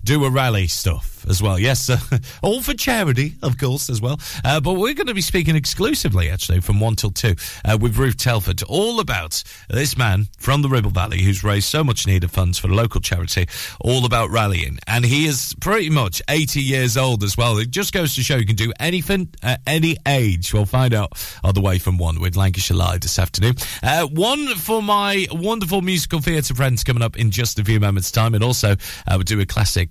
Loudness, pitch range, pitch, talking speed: -19 LUFS, 100-145 Hz, 120 Hz, 225 wpm